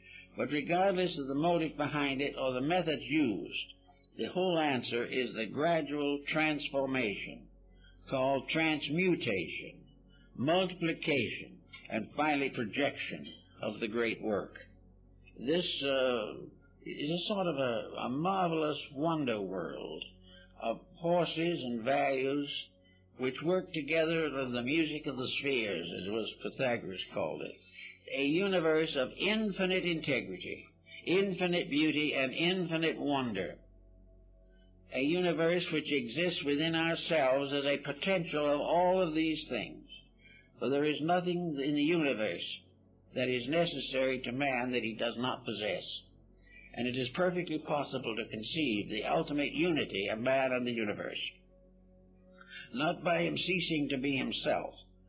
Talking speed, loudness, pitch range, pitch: 130 wpm, -33 LUFS, 120-165 Hz, 145 Hz